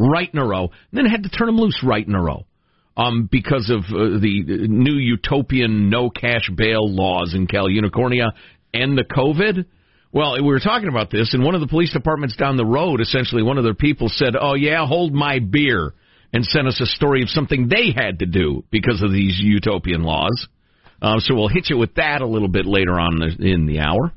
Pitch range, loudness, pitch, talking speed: 100-140 Hz, -18 LUFS, 120 Hz, 220 wpm